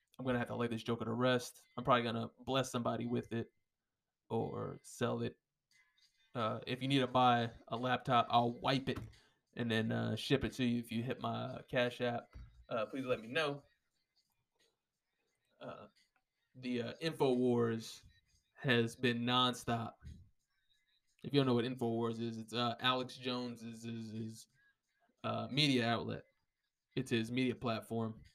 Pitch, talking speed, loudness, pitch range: 120 Hz, 160 wpm, -37 LUFS, 115-125 Hz